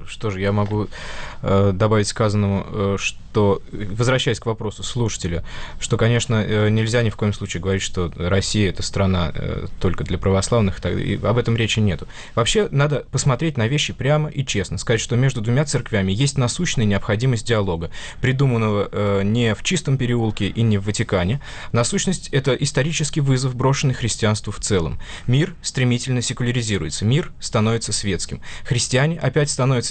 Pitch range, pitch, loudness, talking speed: 100-130 Hz, 110 Hz, -20 LUFS, 160 wpm